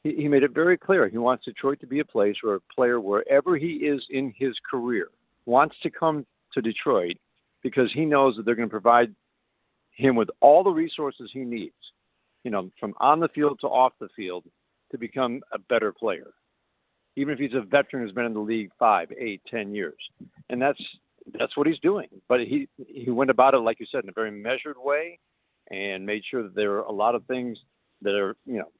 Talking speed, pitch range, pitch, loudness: 215 wpm, 115-145 Hz, 130 Hz, -25 LUFS